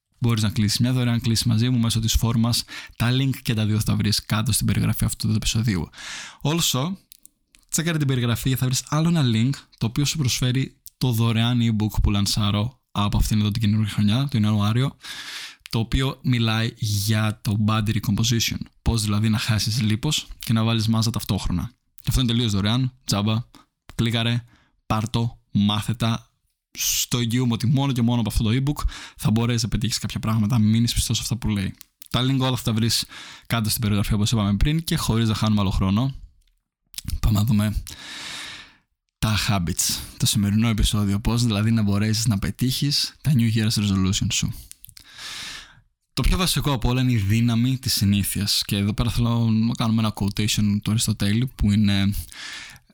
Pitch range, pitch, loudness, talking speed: 105-120 Hz, 115 Hz, -22 LUFS, 180 wpm